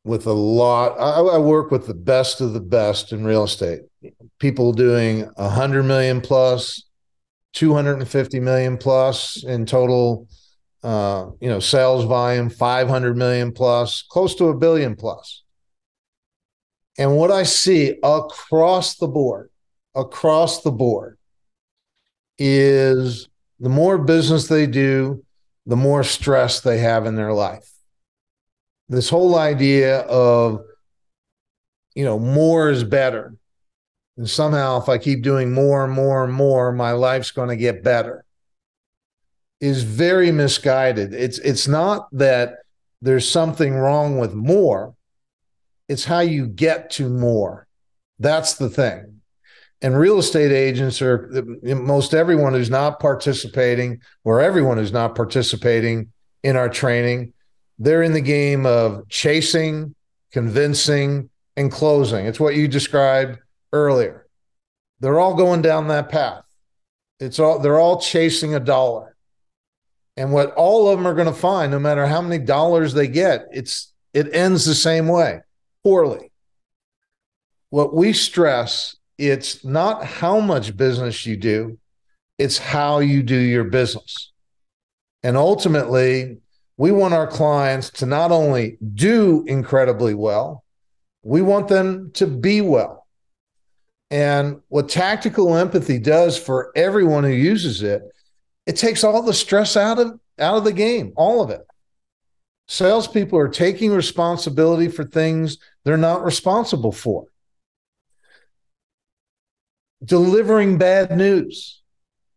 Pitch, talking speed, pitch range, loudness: 135 Hz, 130 wpm, 120-160 Hz, -18 LUFS